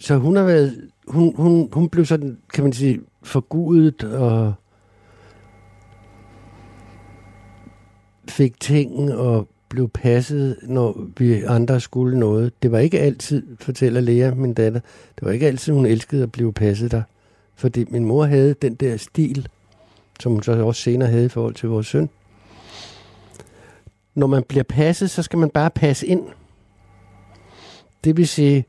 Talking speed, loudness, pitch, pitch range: 155 wpm, -19 LUFS, 120 Hz, 105-140 Hz